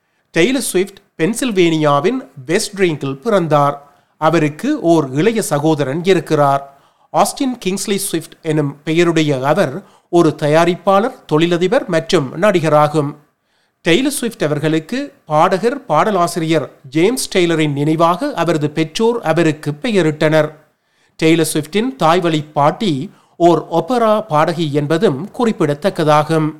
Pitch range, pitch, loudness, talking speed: 155-195 Hz, 165 Hz, -15 LUFS, 95 wpm